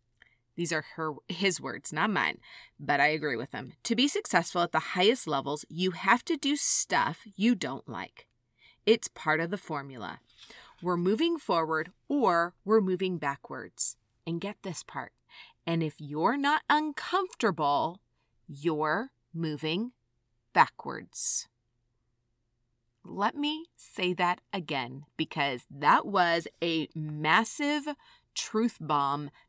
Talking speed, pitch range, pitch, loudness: 130 wpm, 145-220 Hz, 170 Hz, -29 LUFS